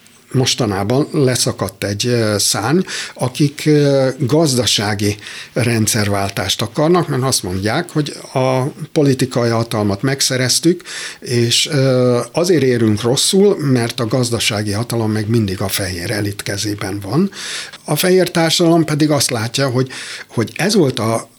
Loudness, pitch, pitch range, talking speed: -16 LUFS, 130 Hz, 110-150 Hz, 115 wpm